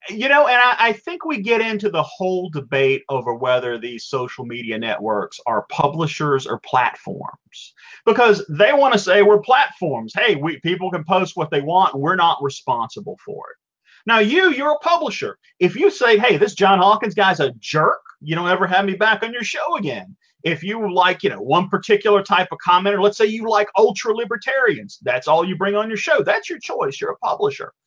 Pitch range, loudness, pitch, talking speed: 170-235 Hz, -18 LUFS, 200 Hz, 205 wpm